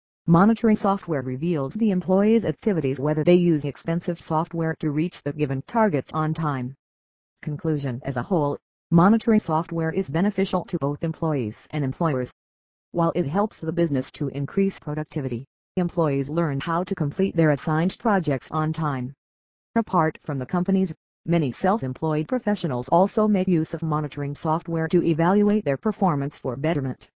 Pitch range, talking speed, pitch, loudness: 140-180 Hz, 150 wpm, 160 Hz, -24 LUFS